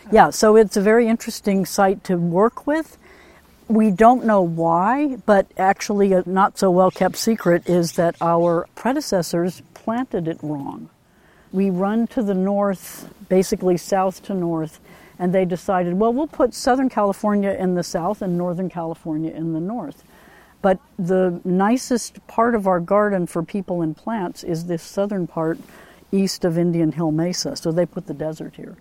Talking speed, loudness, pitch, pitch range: 170 wpm, -20 LUFS, 190 Hz, 175-215 Hz